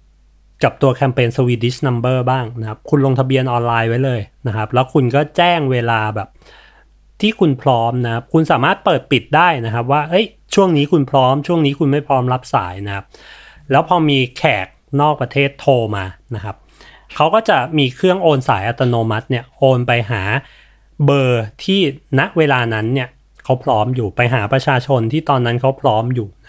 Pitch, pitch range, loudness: 130 Hz, 115-145 Hz, -15 LUFS